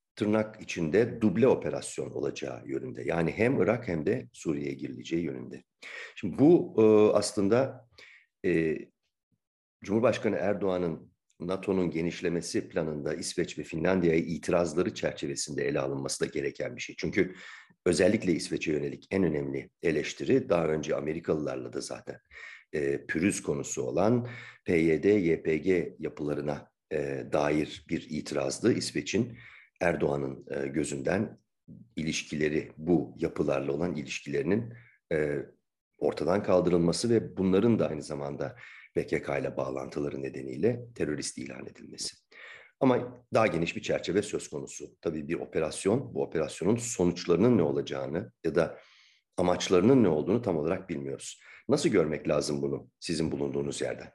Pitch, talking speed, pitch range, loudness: 80 Hz, 120 wpm, 70-95 Hz, -29 LUFS